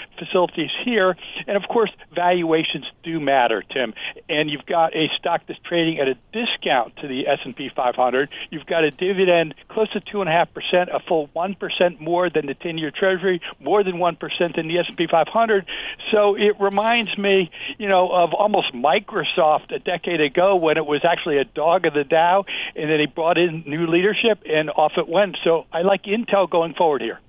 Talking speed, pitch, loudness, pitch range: 205 wpm, 175 Hz, -20 LUFS, 160-195 Hz